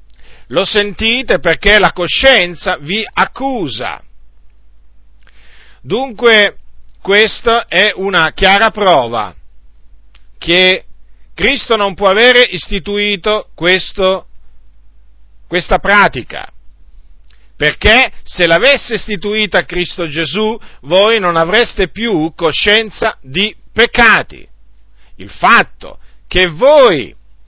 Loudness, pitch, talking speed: -11 LUFS, 185 Hz, 85 wpm